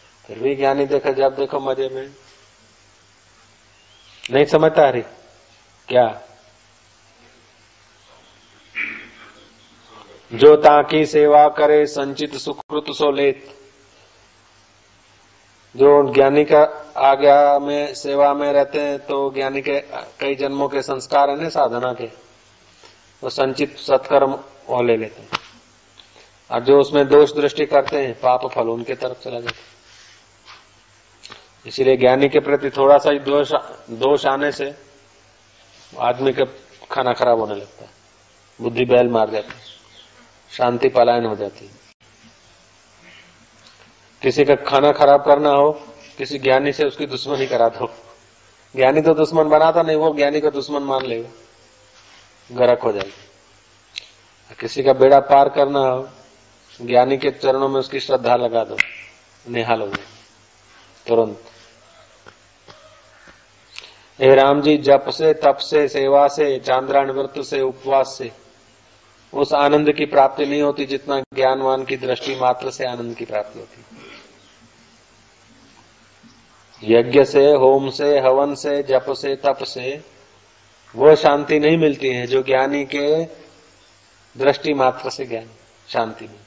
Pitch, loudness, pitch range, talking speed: 135 Hz, -17 LUFS, 115-140 Hz, 125 wpm